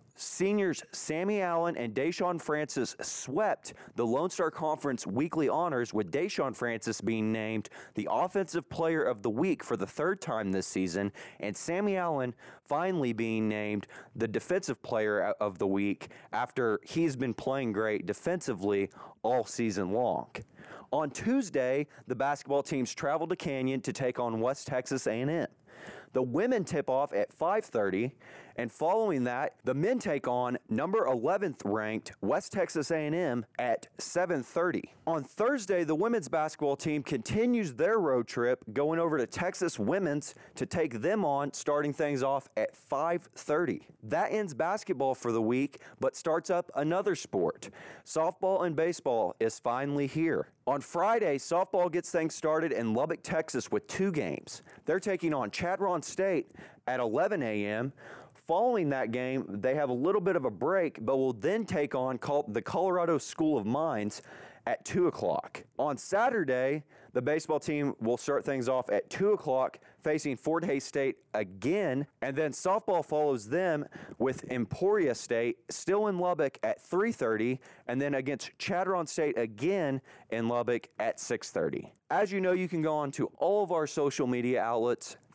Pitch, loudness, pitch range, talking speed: 145 Hz, -31 LUFS, 125-170 Hz, 160 wpm